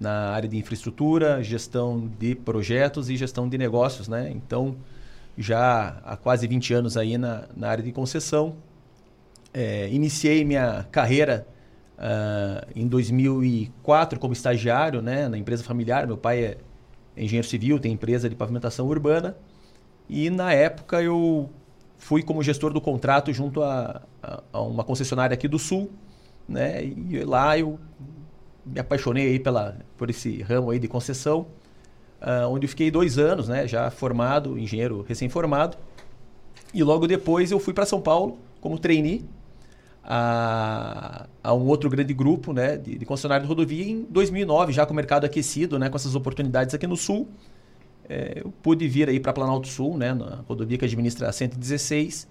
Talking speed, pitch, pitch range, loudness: 165 wpm, 130 Hz, 120-150 Hz, -24 LUFS